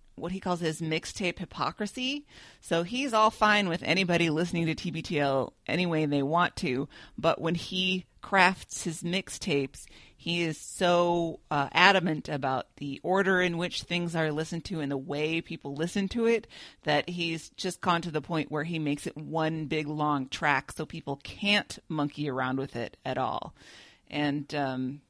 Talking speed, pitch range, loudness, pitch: 175 wpm, 145-180 Hz, -29 LUFS, 165 Hz